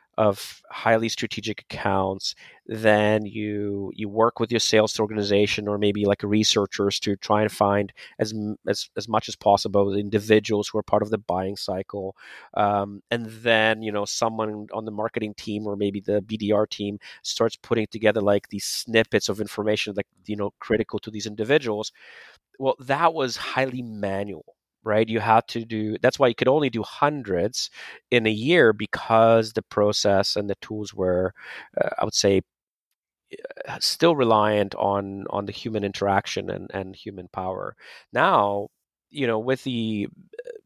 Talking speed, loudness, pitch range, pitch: 165 wpm, -24 LUFS, 100-110 Hz, 105 Hz